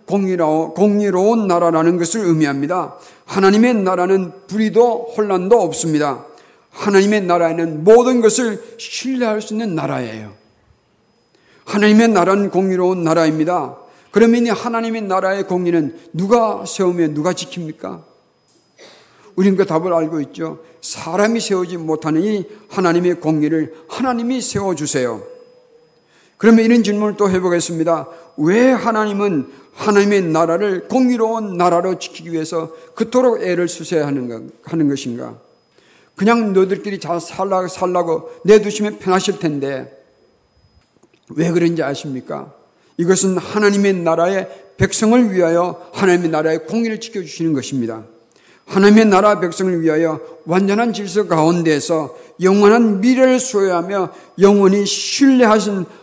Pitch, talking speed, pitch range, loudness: 185 Hz, 315 characters per minute, 165-210 Hz, -16 LUFS